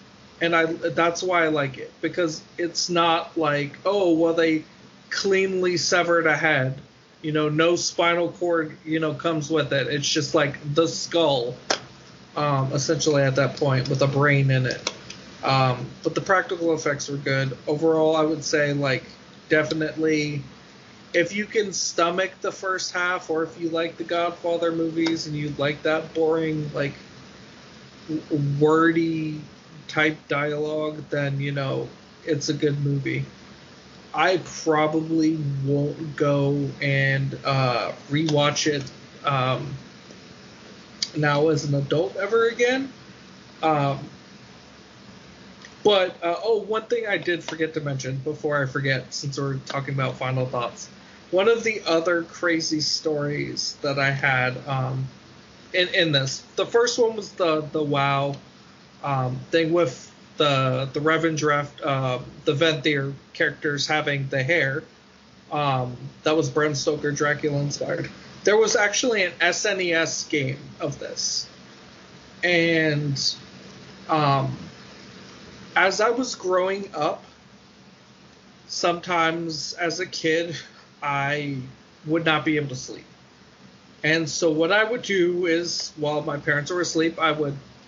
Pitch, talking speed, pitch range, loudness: 155 Hz, 140 wpm, 140-170 Hz, -23 LUFS